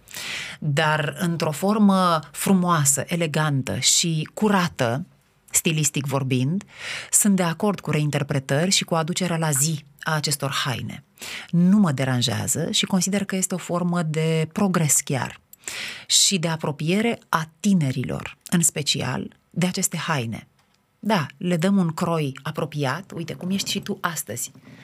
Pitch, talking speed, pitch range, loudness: 165 Hz, 135 wpm, 150-190 Hz, -22 LUFS